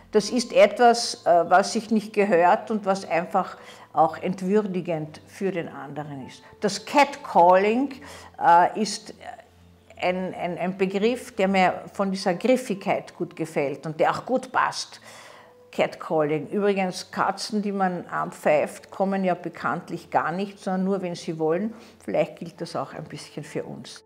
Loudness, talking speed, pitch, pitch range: -24 LUFS, 145 wpm, 190 Hz, 175-215 Hz